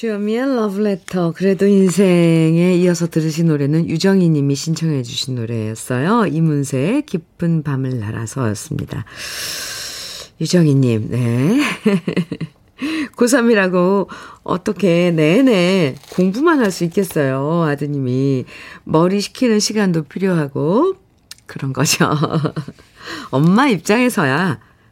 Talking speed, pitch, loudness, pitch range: 250 characters per minute, 170 Hz, -16 LUFS, 145-200 Hz